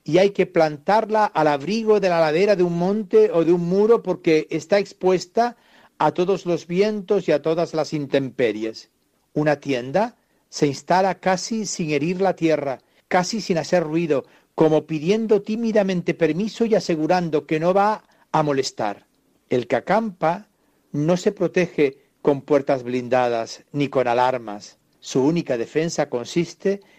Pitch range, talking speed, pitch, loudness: 150-200 Hz, 150 wpm, 170 Hz, -21 LUFS